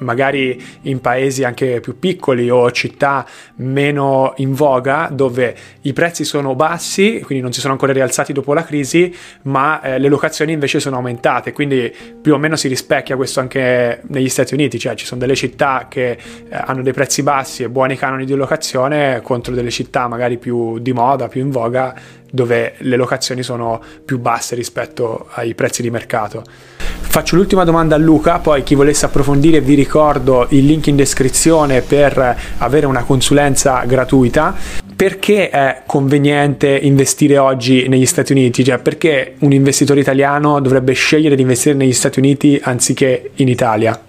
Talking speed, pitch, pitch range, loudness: 165 wpm, 135 Hz, 125-145 Hz, -14 LUFS